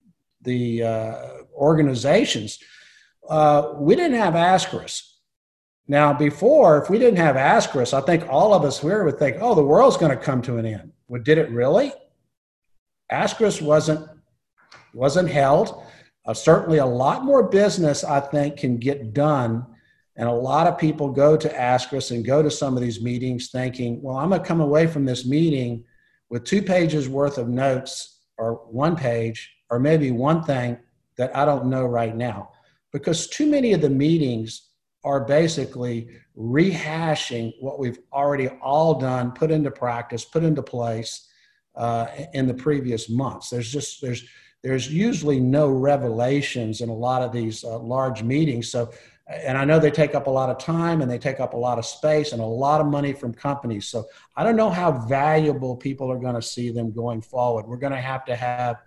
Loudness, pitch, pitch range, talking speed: -21 LUFS, 135 Hz, 120-155 Hz, 185 wpm